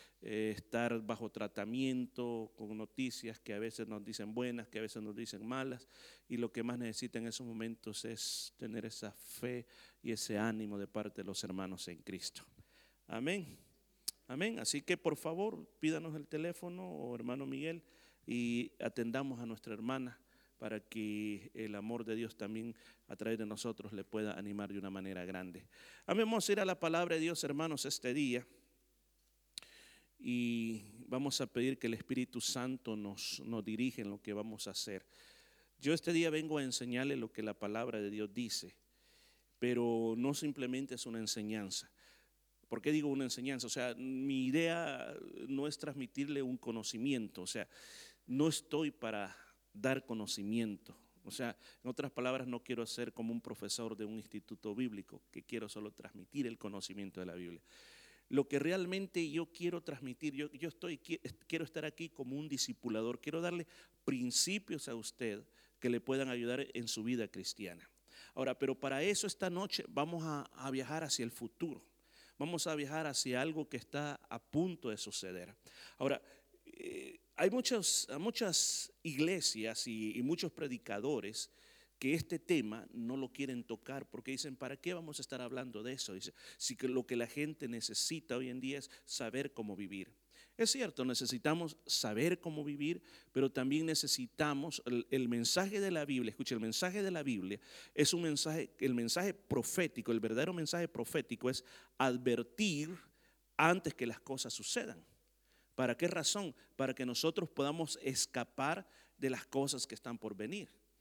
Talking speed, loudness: 170 wpm, -39 LUFS